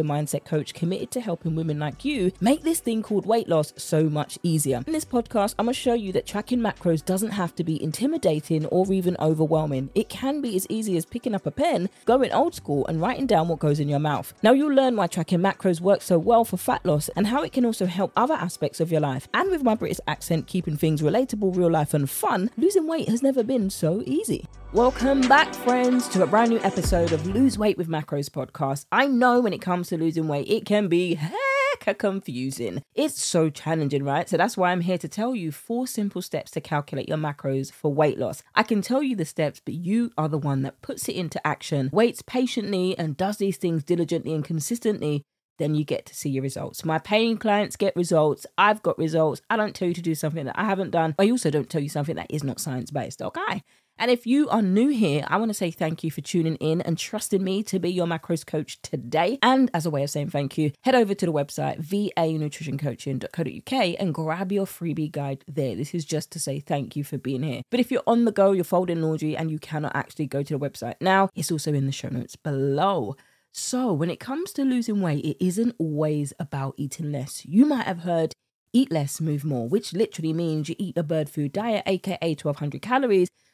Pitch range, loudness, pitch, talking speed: 150-215 Hz, -24 LUFS, 170 Hz, 230 wpm